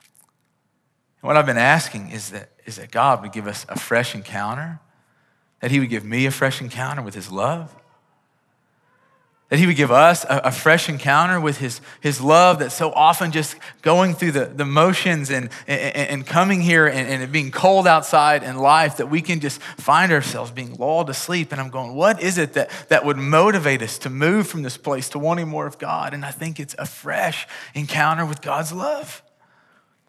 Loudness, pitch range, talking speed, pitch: -19 LUFS, 135-165 Hz, 200 wpm, 150 Hz